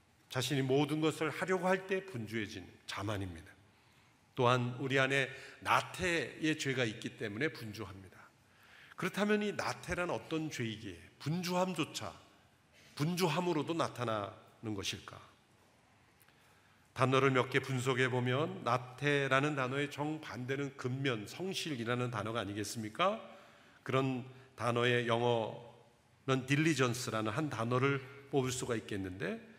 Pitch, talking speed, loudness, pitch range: 125 Hz, 290 characters per minute, -35 LUFS, 110-145 Hz